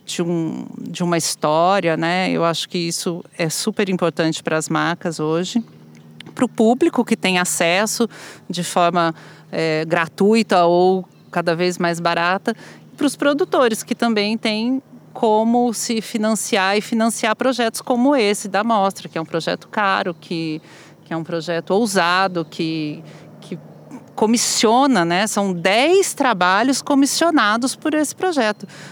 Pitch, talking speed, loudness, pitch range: 190 Hz, 145 wpm, -18 LUFS, 170-230 Hz